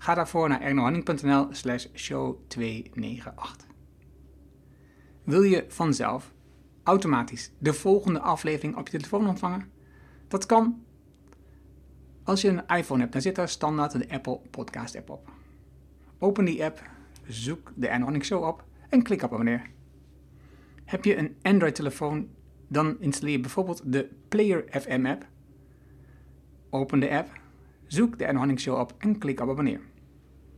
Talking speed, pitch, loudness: 130 wpm, 135 Hz, -27 LUFS